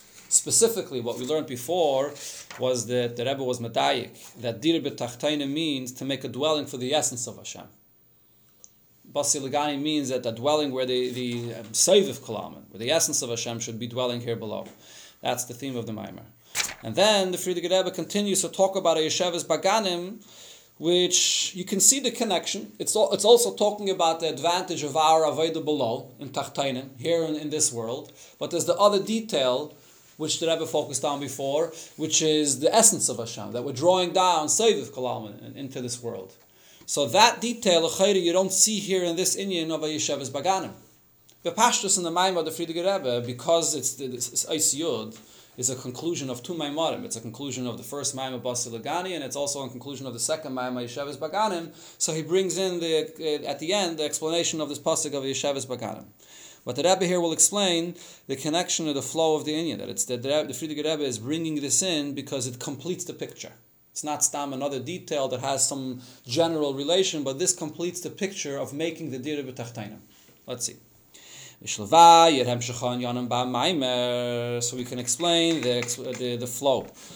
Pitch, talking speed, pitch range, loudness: 150 Hz, 185 wpm, 125-170 Hz, -25 LUFS